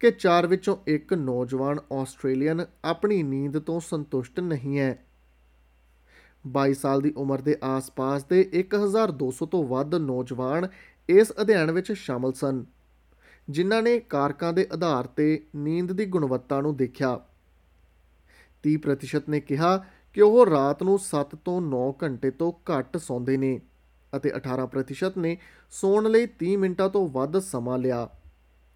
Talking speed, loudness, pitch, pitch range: 135 wpm, -25 LUFS, 145 Hz, 130-180 Hz